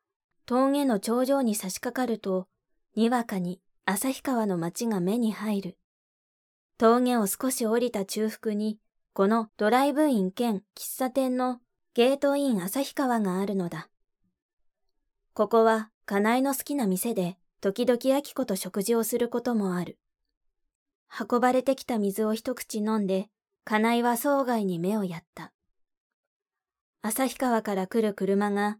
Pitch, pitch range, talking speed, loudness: 225 Hz, 200-255 Hz, 250 characters per minute, -27 LUFS